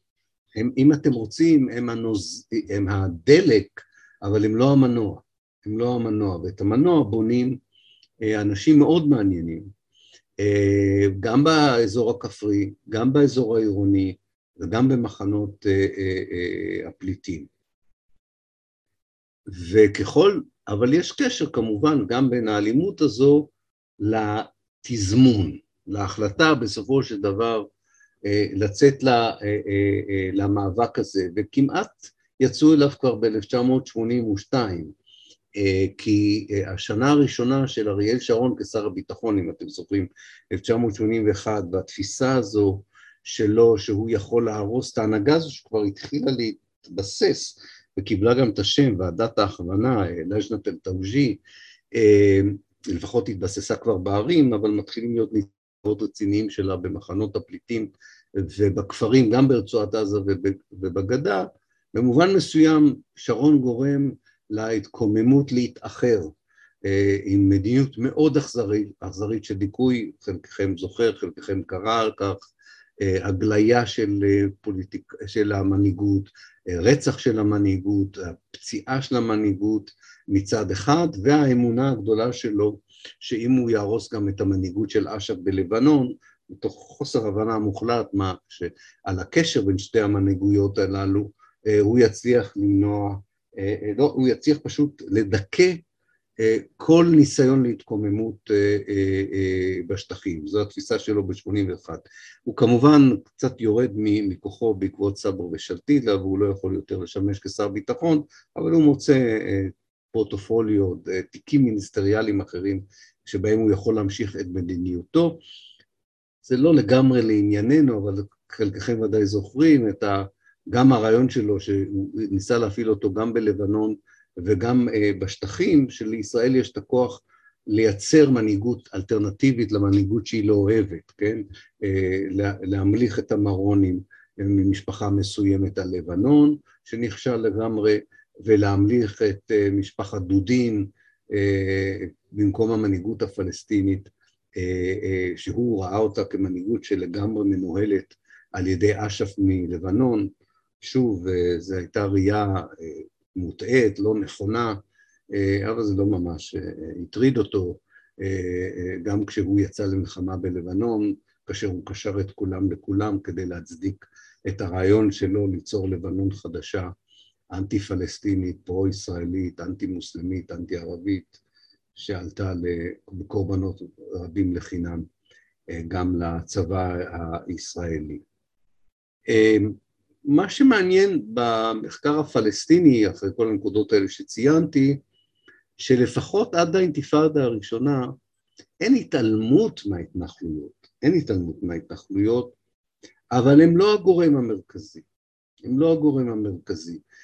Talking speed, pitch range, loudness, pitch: 100 wpm, 100-125 Hz, -22 LUFS, 105 Hz